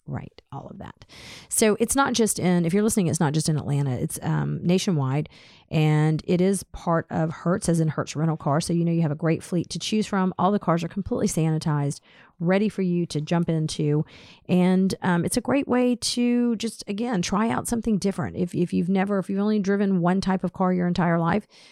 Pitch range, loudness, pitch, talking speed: 160-200 Hz, -24 LUFS, 180 Hz, 225 wpm